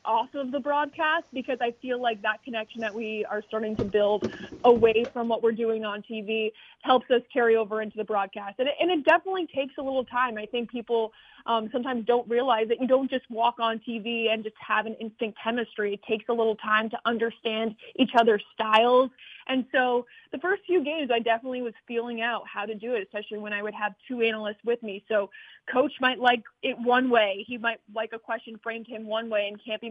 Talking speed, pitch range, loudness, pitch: 225 wpm, 220-250 Hz, -27 LUFS, 230 Hz